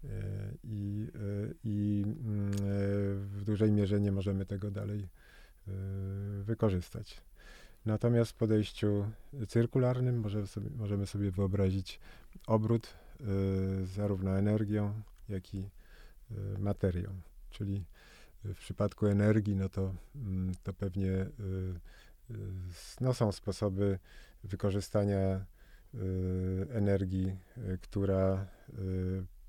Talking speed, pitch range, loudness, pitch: 80 wpm, 95-105 Hz, -34 LUFS, 100 Hz